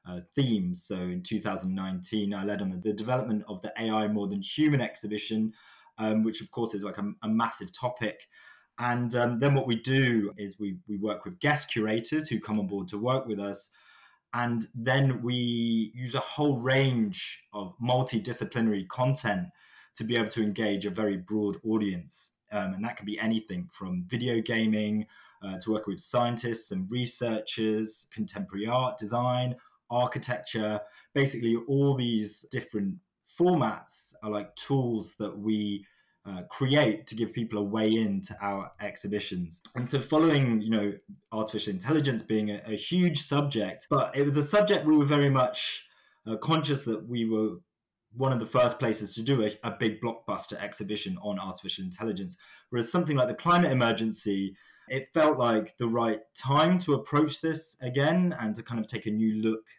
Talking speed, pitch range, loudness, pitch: 175 wpm, 105-130 Hz, -29 LUFS, 110 Hz